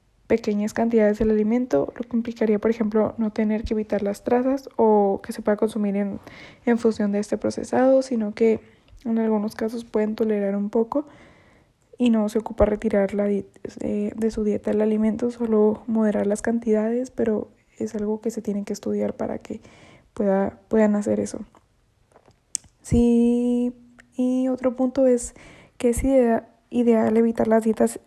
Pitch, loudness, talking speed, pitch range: 220 Hz, -23 LUFS, 165 wpm, 210-235 Hz